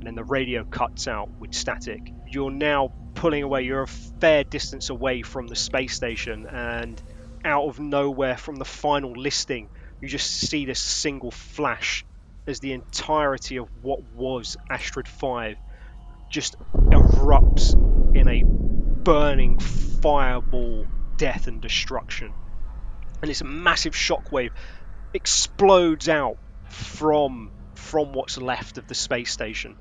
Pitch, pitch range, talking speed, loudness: 130 Hz, 110-145 Hz, 135 wpm, -24 LUFS